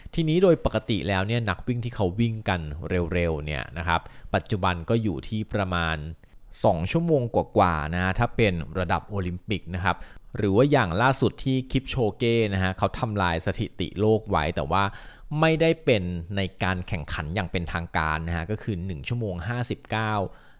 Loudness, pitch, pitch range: -26 LUFS, 100 Hz, 90-115 Hz